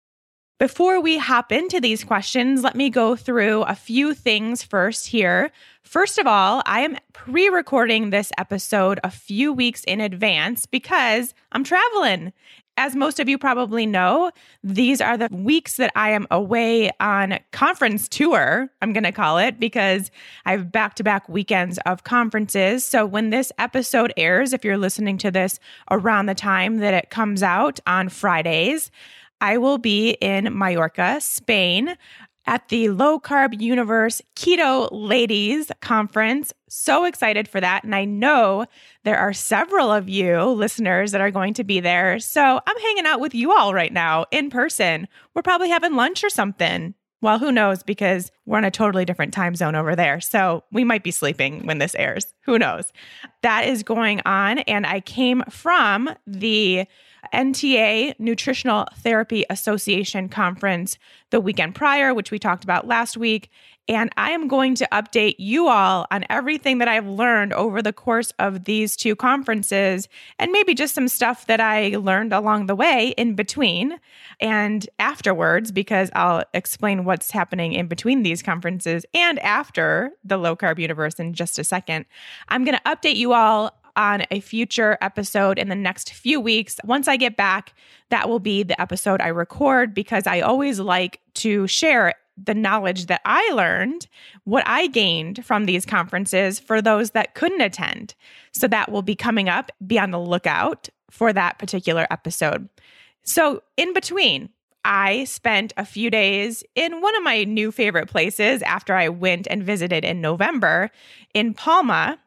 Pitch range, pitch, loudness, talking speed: 195-255 Hz, 215 Hz, -20 LUFS, 170 wpm